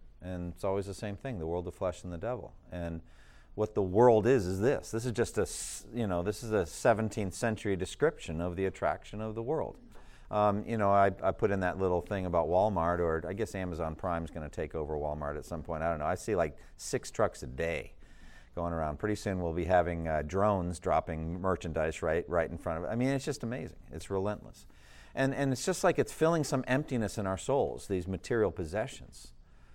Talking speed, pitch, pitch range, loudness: 225 wpm, 95 Hz, 85-105 Hz, -32 LUFS